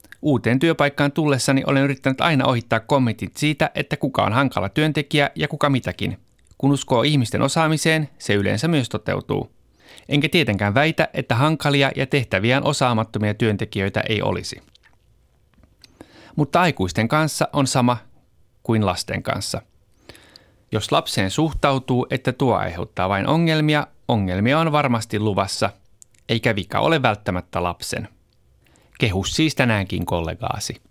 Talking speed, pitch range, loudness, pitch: 125 wpm, 105-145 Hz, -20 LUFS, 125 Hz